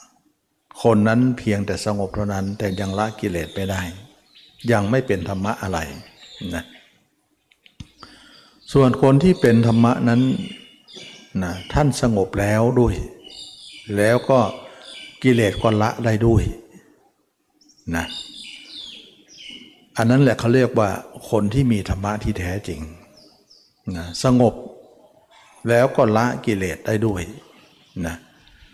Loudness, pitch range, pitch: -20 LUFS, 100-125 Hz, 110 Hz